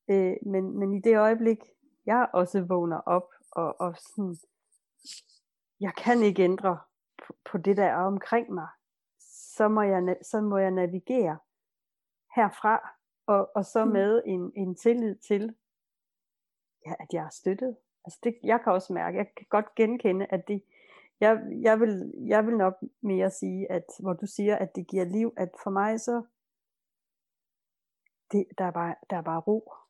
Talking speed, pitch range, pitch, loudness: 165 wpm, 185-225 Hz, 200 Hz, -28 LUFS